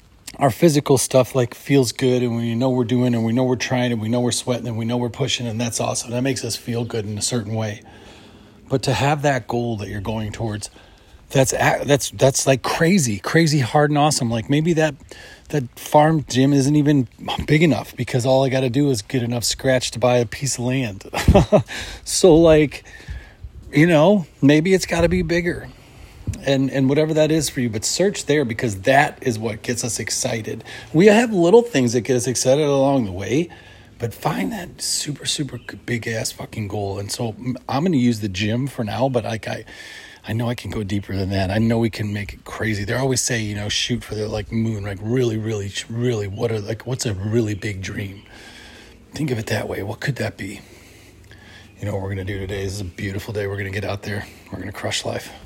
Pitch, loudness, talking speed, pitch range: 120 Hz, -20 LUFS, 230 wpm, 105-135 Hz